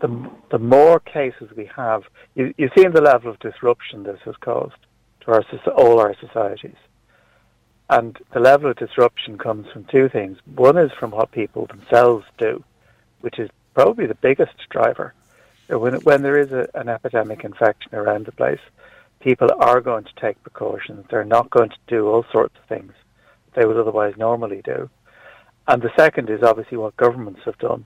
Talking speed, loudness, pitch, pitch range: 175 wpm, -18 LUFS, 120 Hz, 115-150 Hz